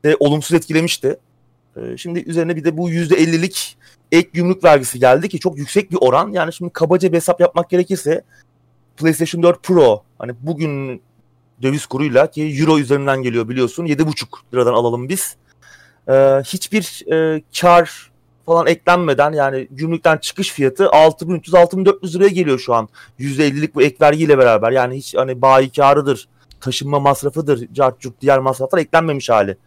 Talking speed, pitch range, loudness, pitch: 140 wpm, 130-170 Hz, -15 LUFS, 155 Hz